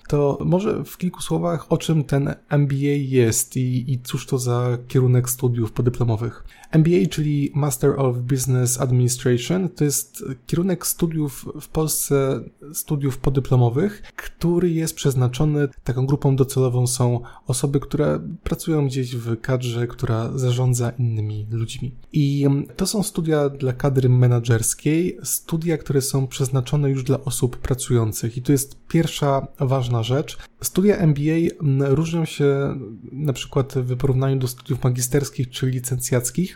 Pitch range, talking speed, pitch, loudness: 125-150 Hz, 135 wpm, 135 Hz, -21 LUFS